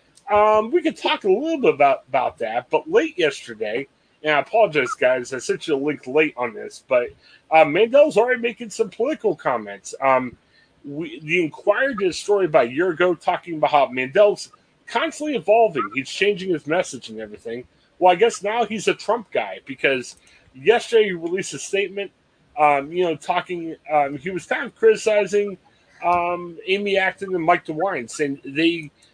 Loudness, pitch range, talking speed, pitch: -20 LUFS, 150-220 Hz, 180 wpm, 180 Hz